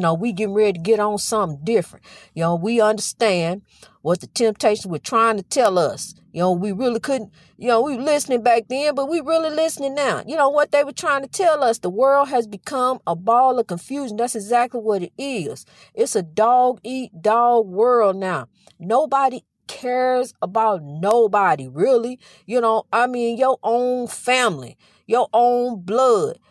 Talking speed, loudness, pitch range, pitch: 185 wpm, -20 LUFS, 210-255 Hz, 235 Hz